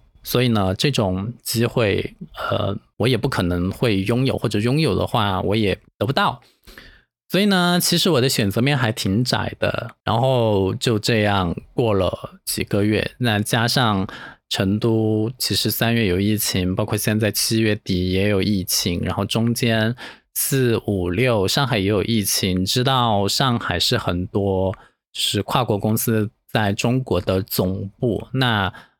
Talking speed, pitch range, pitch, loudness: 220 characters per minute, 100-120 Hz, 110 Hz, -20 LUFS